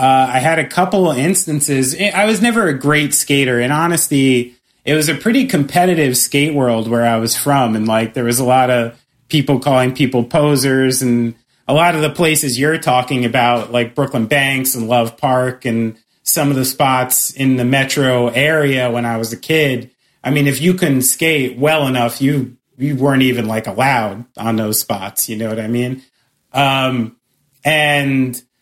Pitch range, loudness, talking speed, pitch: 120-145 Hz, -14 LUFS, 185 wpm, 130 Hz